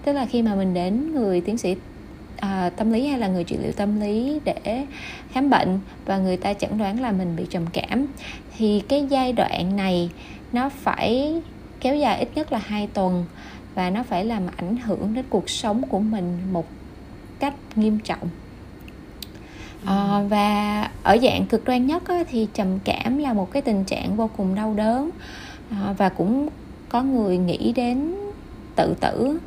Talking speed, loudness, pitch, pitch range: 180 wpm, -23 LUFS, 215 Hz, 190-255 Hz